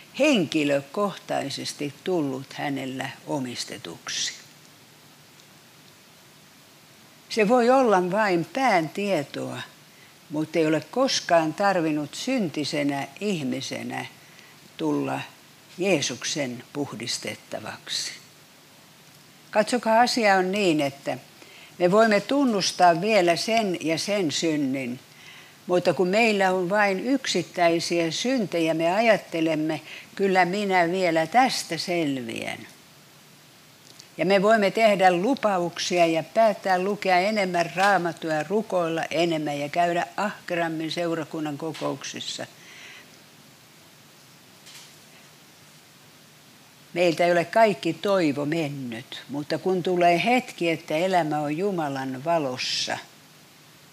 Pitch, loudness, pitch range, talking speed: 170 Hz, -24 LUFS, 150-200 Hz, 90 wpm